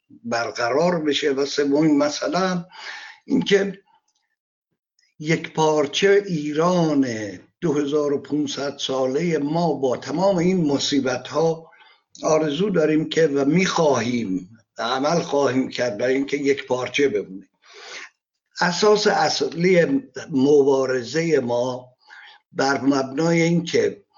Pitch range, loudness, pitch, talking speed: 135-175 Hz, -21 LUFS, 150 Hz, 90 wpm